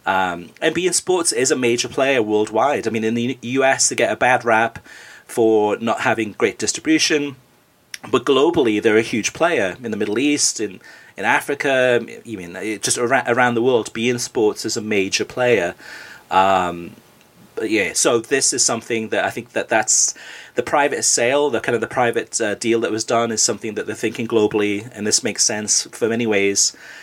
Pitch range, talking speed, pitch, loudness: 105-125 Hz, 195 wpm, 115 Hz, -18 LUFS